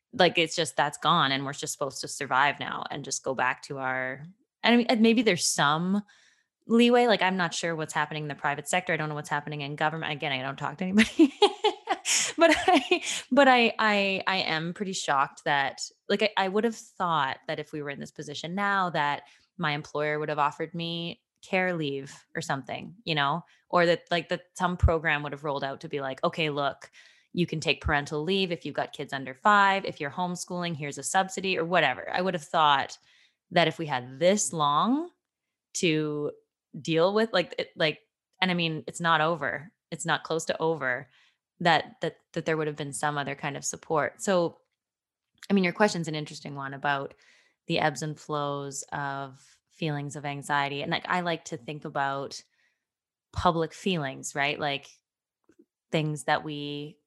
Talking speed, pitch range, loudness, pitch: 195 wpm, 145-185 Hz, -27 LUFS, 160 Hz